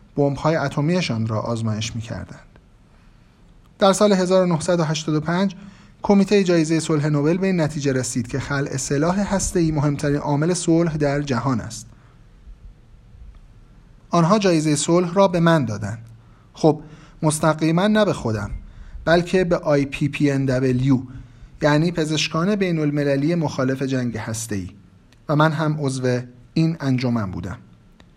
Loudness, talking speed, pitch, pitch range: -20 LUFS, 120 wpm, 145 Hz, 125-165 Hz